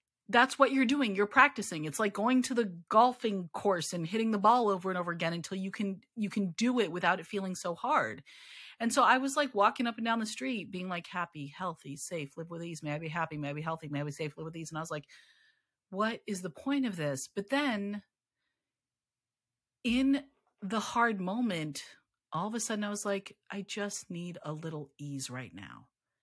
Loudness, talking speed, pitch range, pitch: -32 LUFS, 225 wpm, 160-230 Hz, 195 Hz